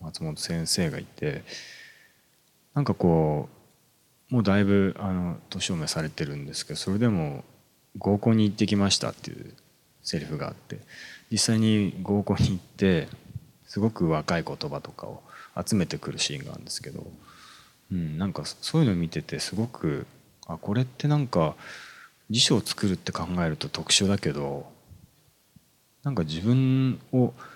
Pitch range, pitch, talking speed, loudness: 85-115 Hz, 100 Hz, 305 characters per minute, -27 LUFS